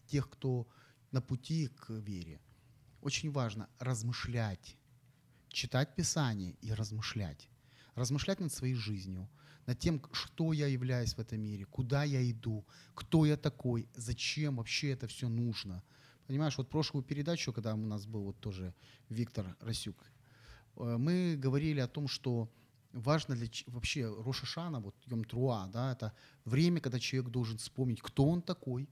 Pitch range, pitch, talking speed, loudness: 115-140 Hz, 125 Hz, 145 wpm, -37 LUFS